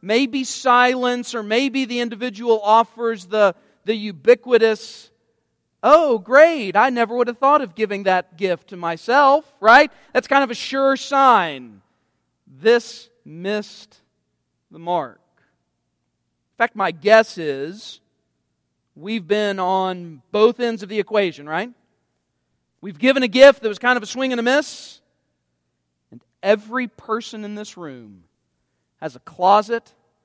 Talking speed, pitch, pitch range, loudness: 140 wpm, 215 Hz, 155-245 Hz, -18 LUFS